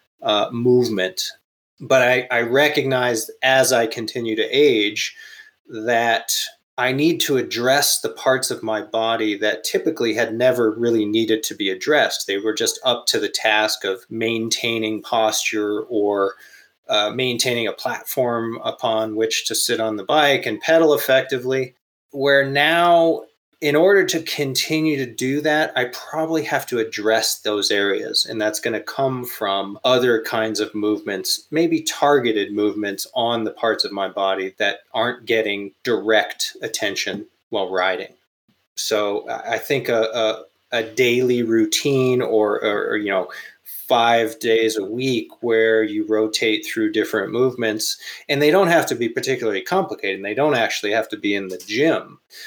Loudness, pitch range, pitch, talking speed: -19 LUFS, 110-145 Hz, 115 Hz, 160 wpm